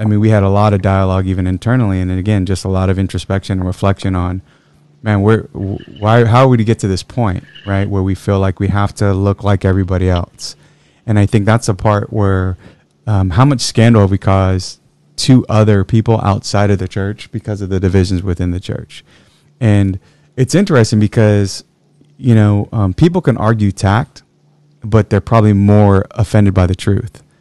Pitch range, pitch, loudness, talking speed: 95-110 Hz, 100 Hz, -13 LUFS, 195 wpm